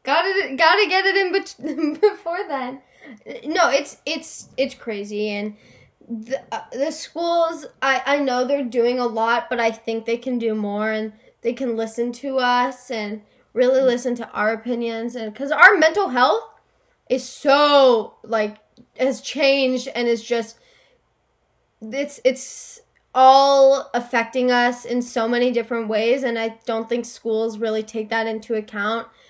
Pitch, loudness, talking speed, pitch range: 245 Hz, -20 LUFS, 160 wpm, 230-275 Hz